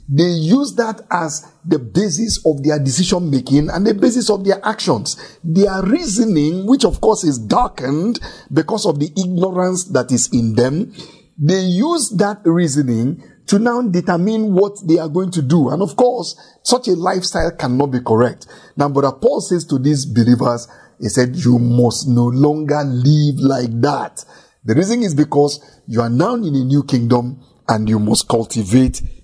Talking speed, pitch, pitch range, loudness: 170 wpm, 155 Hz, 130-190 Hz, -16 LUFS